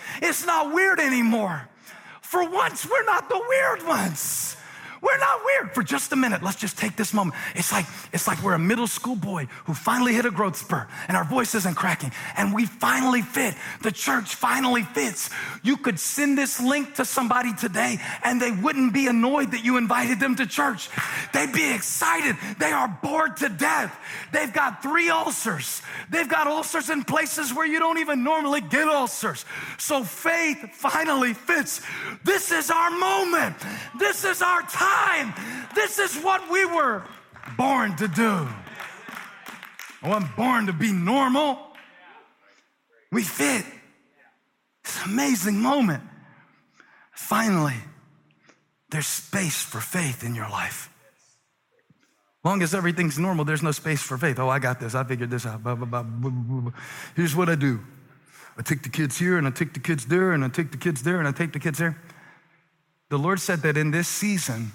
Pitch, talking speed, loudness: 215 Hz, 170 wpm, -24 LUFS